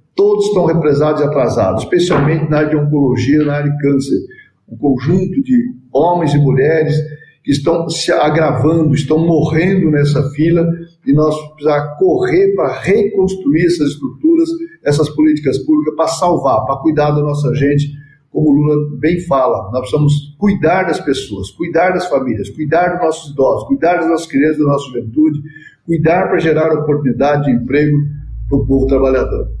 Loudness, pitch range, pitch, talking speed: -13 LUFS, 145-165 Hz, 150 Hz, 160 wpm